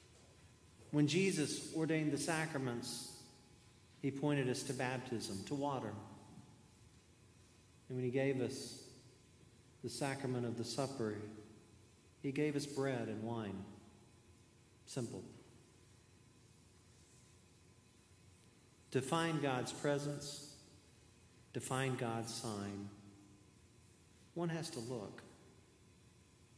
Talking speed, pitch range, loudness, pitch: 95 wpm, 105-130 Hz, -41 LUFS, 115 Hz